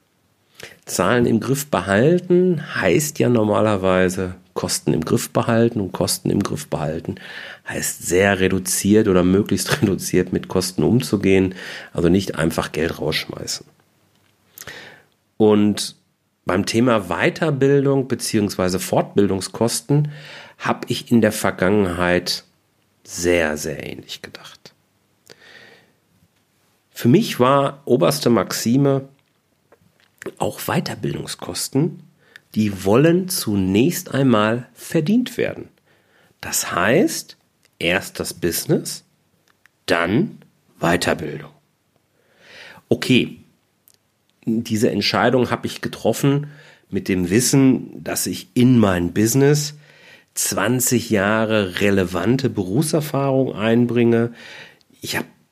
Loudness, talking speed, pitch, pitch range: -19 LUFS, 95 wpm, 115 Hz, 95-135 Hz